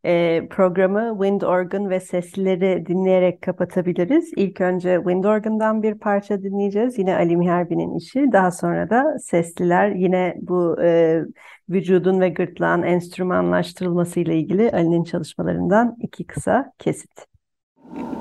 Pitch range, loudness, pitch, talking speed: 175-200 Hz, -20 LUFS, 185 Hz, 115 wpm